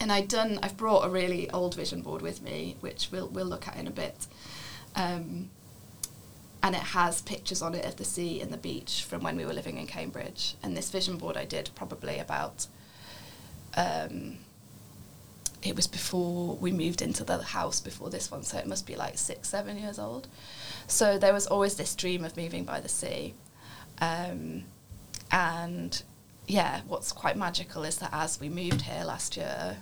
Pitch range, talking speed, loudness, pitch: 145-190 Hz, 190 wpm, -32 LUFS, 175 Hz